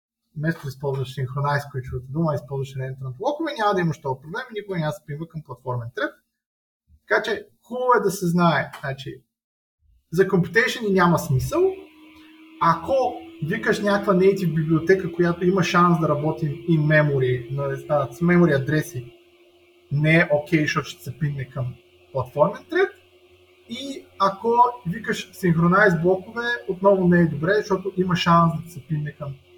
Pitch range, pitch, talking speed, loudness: 140-200 Hz, 165 Hz, 160 wpm, -22 LUFS